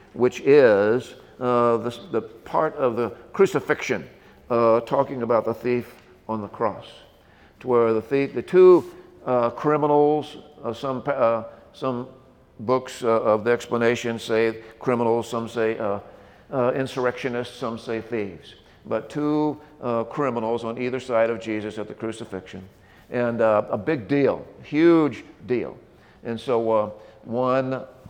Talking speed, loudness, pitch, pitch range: 145 wpm, -23 LUFS, 120 Hz, 115-135 Hz